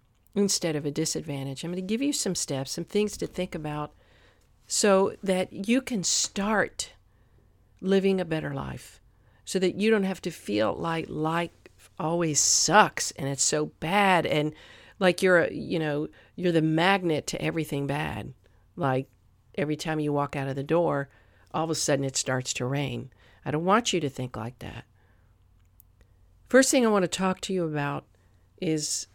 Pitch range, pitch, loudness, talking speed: 115-180 Hz, 150 Hz, -26 LUFS, 180 wpm